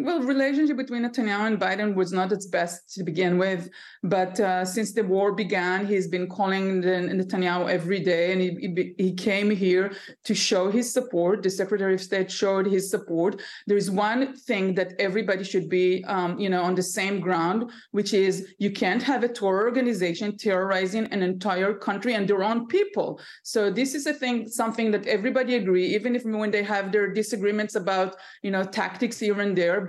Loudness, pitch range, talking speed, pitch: -25 LUFS, 185-220 Hz, 195 wpm, 200 Hz